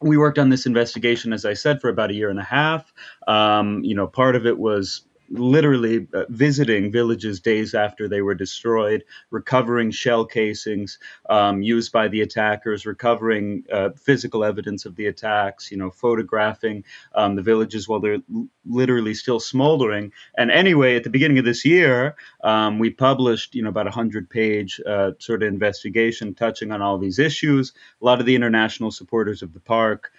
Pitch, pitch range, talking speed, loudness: 110 Hz, 105-120 Hz, 185 wpm, -20 LUFS